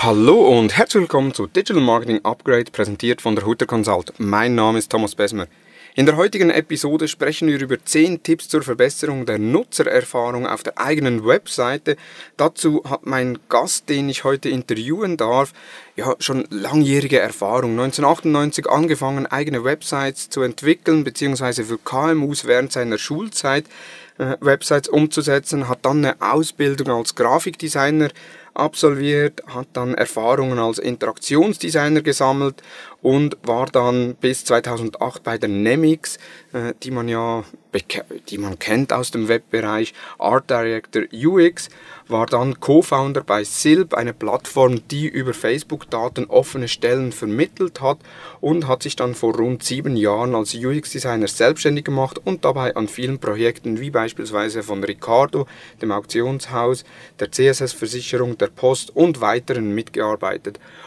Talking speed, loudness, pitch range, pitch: 140 wpm, -19 LUFS, 115-150 Hz, 130 Hz